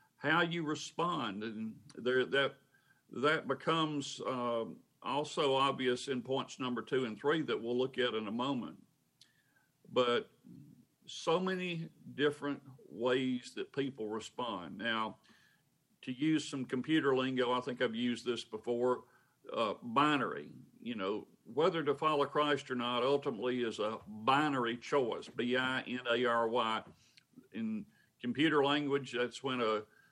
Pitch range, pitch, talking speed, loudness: 120-145 Hz, 130 Hz, 140 wpm, -35 LUFS